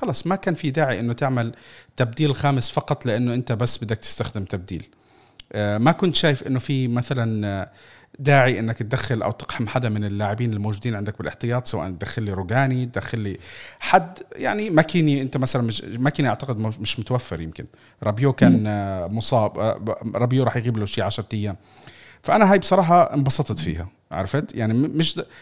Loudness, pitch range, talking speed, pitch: -22 LUFS, 105-135 Hz, 160 wpm, 120 Hz